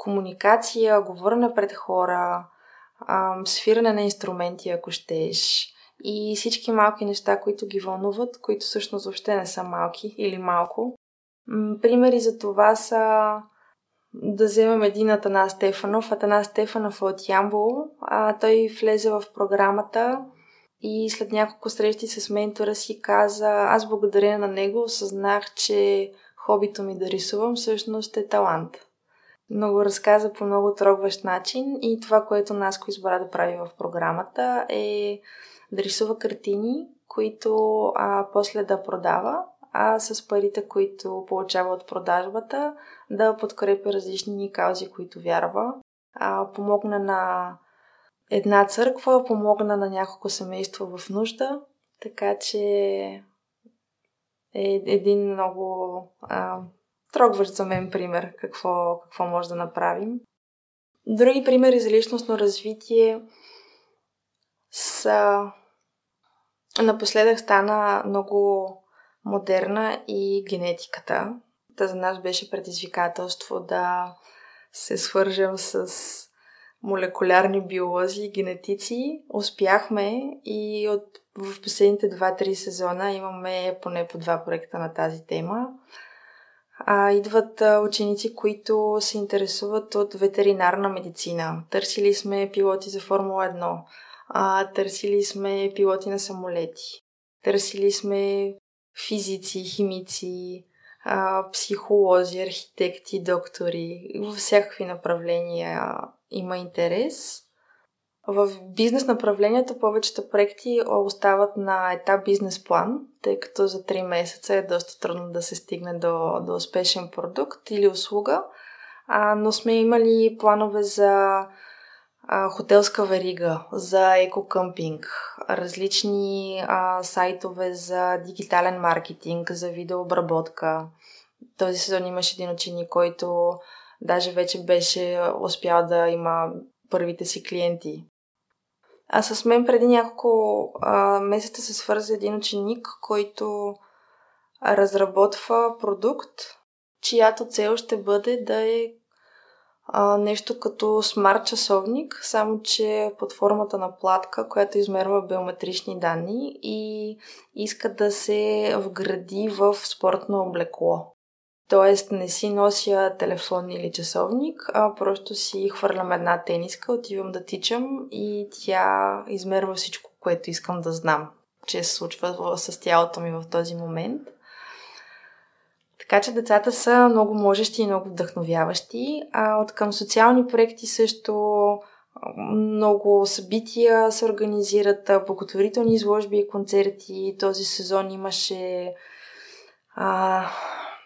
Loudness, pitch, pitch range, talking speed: -23 LUFS, 200 Hz, 185-215 Hz, 115 wpm